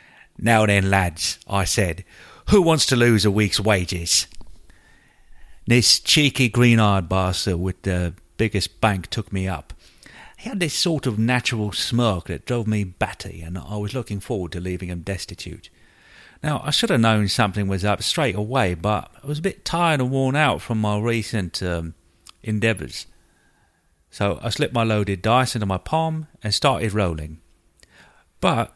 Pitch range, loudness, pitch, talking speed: 90-120 Hz, -21 LUFS, 105 Hz, 170 wpm